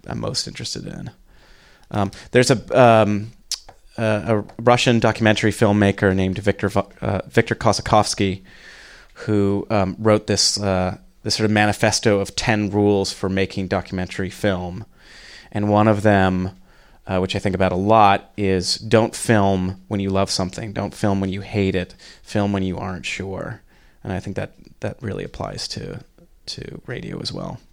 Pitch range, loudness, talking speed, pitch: 95-110 Hz, -20 LUFS, 160 wpm, 100 Hz